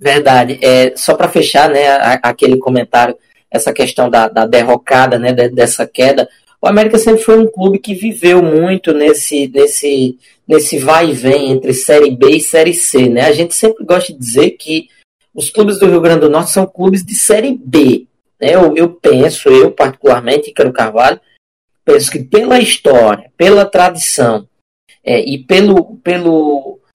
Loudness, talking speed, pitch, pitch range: -9 LUFS, 165 wpm, 165 Hz, 135-200 Hz